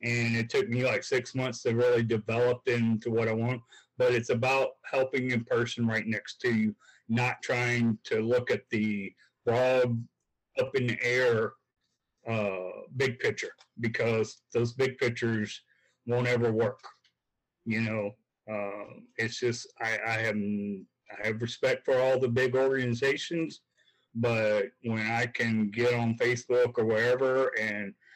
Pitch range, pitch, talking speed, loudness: 110-125 Hz, 115 Hz, 150 wpm, -29 LUFS